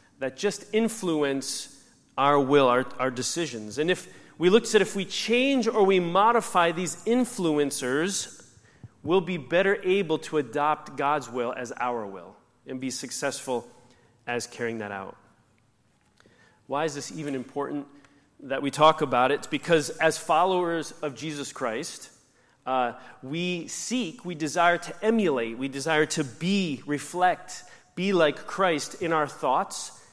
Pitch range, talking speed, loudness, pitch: 130-180 Hz, 145 wpm, -26 LUFS, 150 Hz